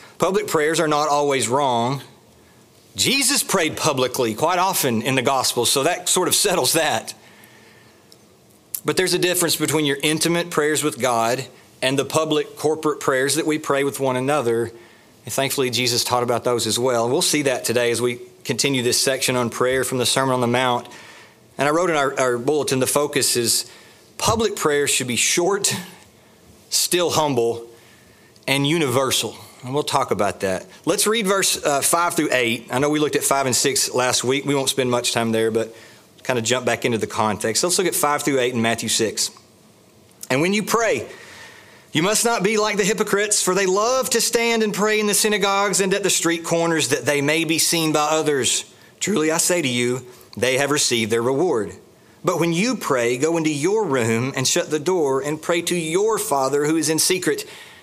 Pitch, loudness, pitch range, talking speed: 145 Hz, -19 LUFS, 125-170 Hz, 200 wpm